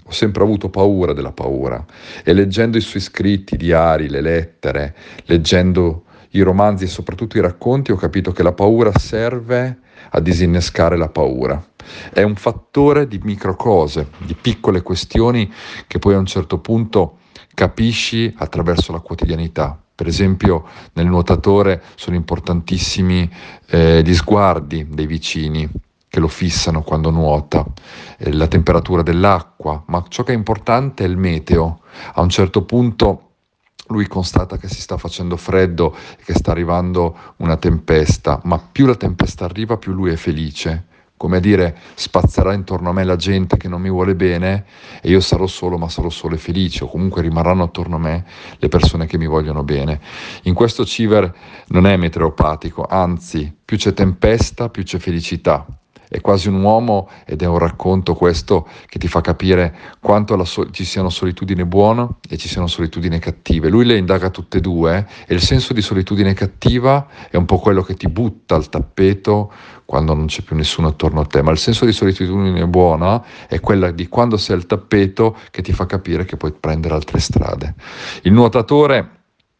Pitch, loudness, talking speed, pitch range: 90 Hz, -16 LUFS, 175 wpm, 85-100 Hz